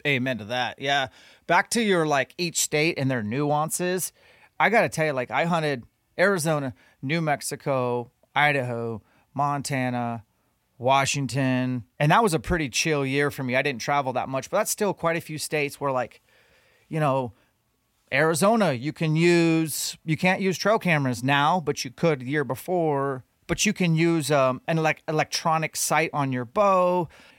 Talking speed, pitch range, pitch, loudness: 175 wpm, 130-165 Hz, 145 Hz, -24 LUFS